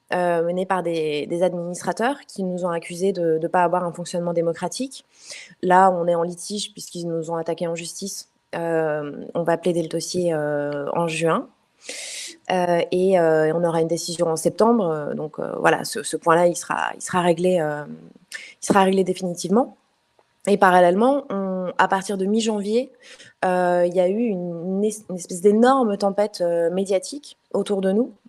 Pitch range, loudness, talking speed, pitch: 170-200 Hz, -22 LUFS, 180 wpm, 180 Hz